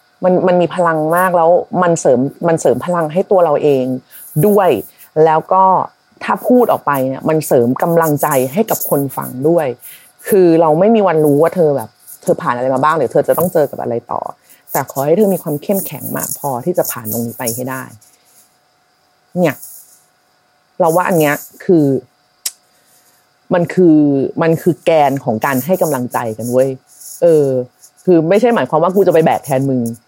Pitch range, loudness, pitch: 130-180 Hz, -14 LUFS, 160 Hz